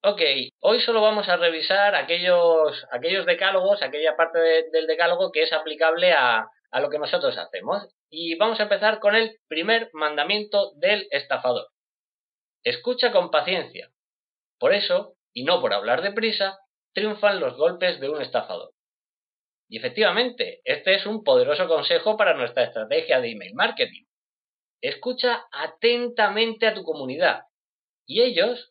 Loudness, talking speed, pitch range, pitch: -22 LUFS, 145 wpm, 170-250 Hz, 210 Hz